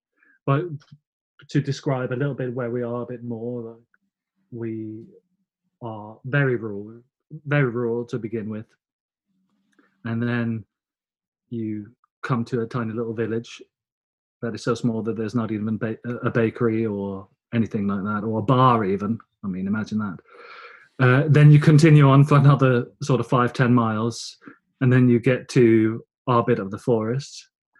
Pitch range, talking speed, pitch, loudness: 115-145 Hz, 165 wpm, 120 Hz, -21 LUFS